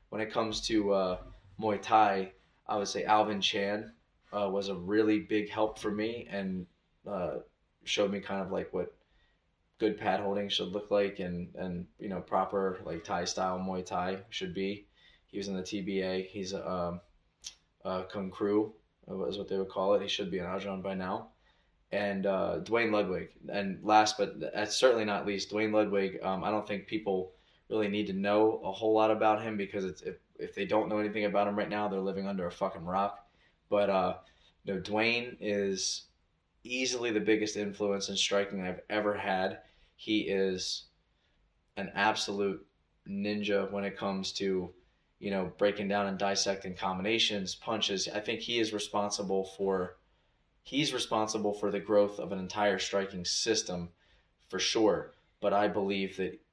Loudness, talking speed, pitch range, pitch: -32 LUFS, 180 wpm, 95-105 Hz, 100 Hz